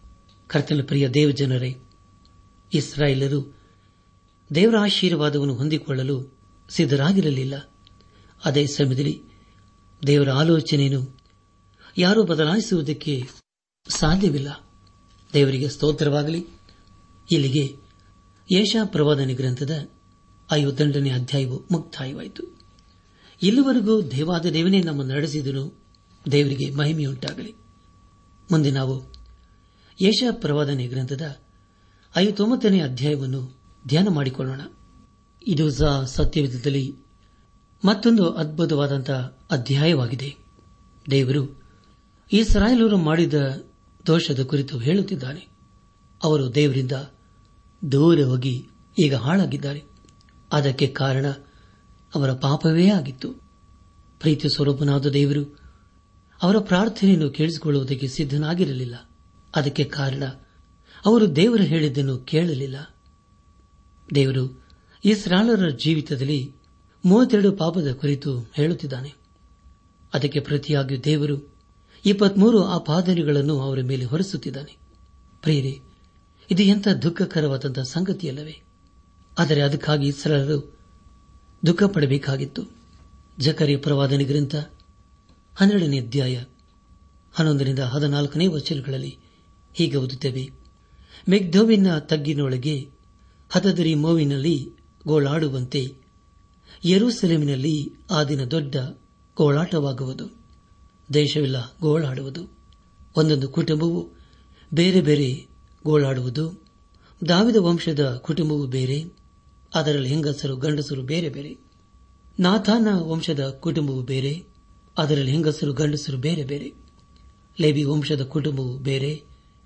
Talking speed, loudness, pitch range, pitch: 75 wpm, -22 LUFS, 125-160 Hz, 145 Hz